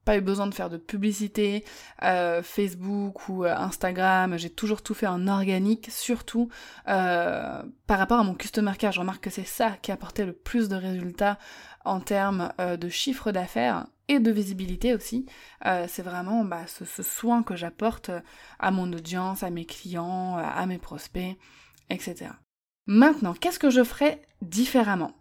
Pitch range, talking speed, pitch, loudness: 180-220 Hz, 175 wpm, 195 Hz, -27 LUFS